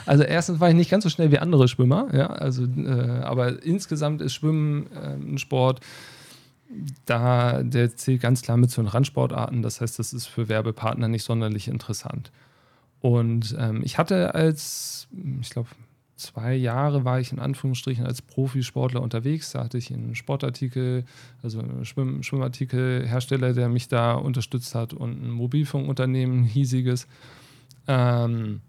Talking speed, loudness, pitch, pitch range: 155 wpm, -24 LUFS, 130 Hz, 120-140 Hz